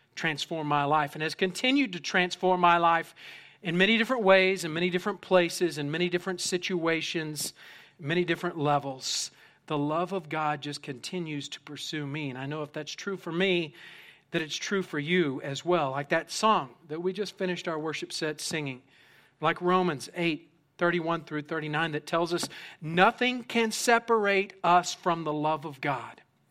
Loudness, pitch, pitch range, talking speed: -28 LUFS, 170 Hz, 150-180 Hz, 175 wpm